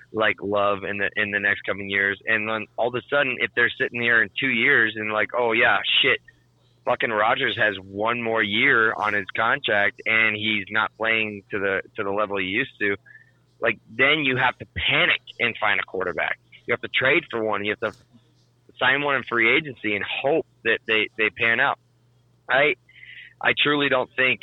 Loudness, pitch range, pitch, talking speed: -21 LUFS, 105-125 Hz, 110 Hz, 205 wpm